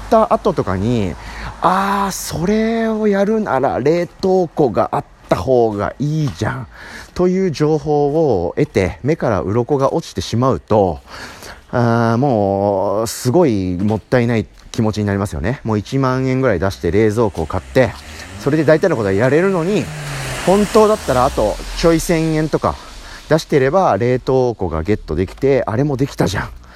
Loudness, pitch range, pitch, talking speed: -16 LUFS, 105-165 Hz, 130 Hz, 310 characters per minute